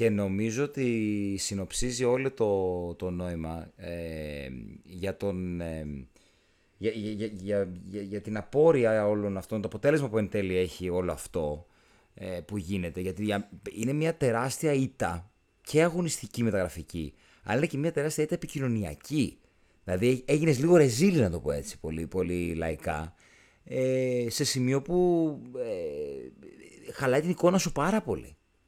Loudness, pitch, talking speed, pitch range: -29 LUFS, 105 Hz, 140 wpm, 90-135 Hz